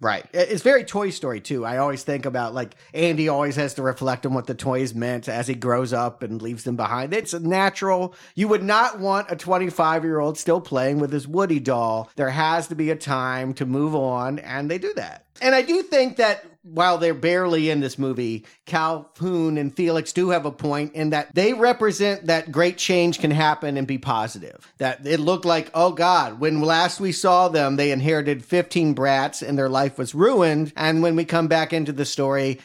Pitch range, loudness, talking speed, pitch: 135-175 Hz, -22 LUFS, 210 wpm, 155 Hz